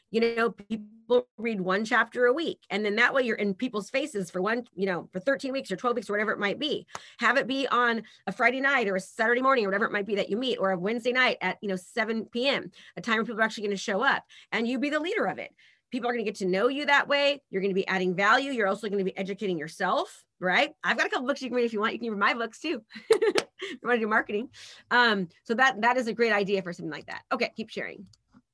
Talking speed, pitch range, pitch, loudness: 290 wpm, 195-250 Hz, 225 Hz, -27 LUFS